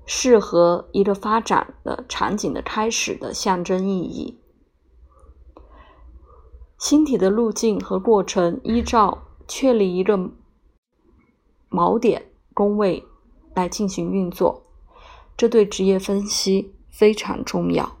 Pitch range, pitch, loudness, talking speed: 175-220 Hz, 195 Hz, -20 LUFS, 165 characters per minute